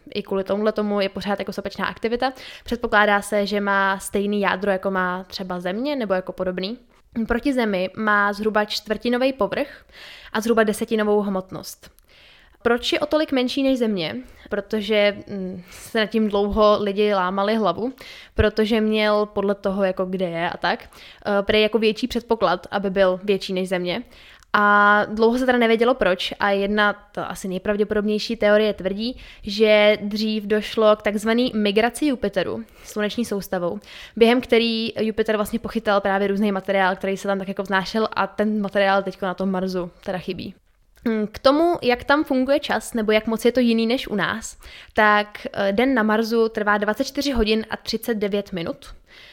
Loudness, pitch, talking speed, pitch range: -21 LUFS, 210 Hz, 165 wpm, 200-230 Hz